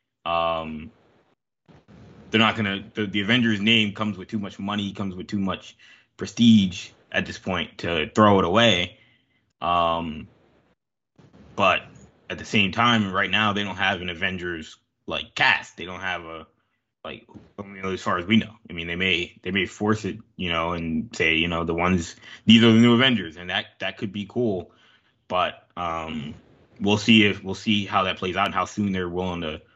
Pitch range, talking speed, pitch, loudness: 90-110 Hz, 190 wpm, 100 Hz, -22 LUFS